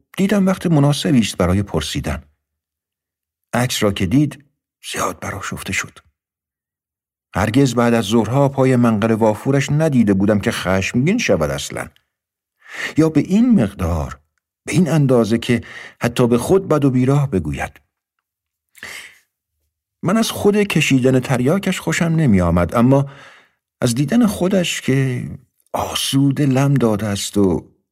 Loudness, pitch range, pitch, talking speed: -17 LUFS, 95-145 Hz, 120 Hz, 130 wpm